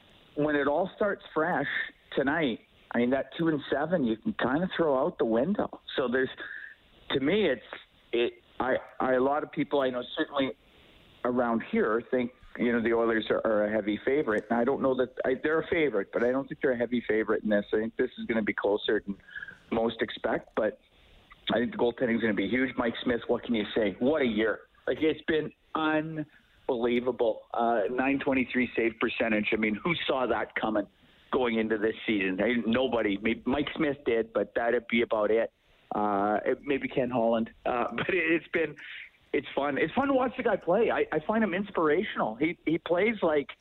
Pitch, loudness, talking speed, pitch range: 125 Hz, -29 LUFS, 205 wpm, 115-150 Hz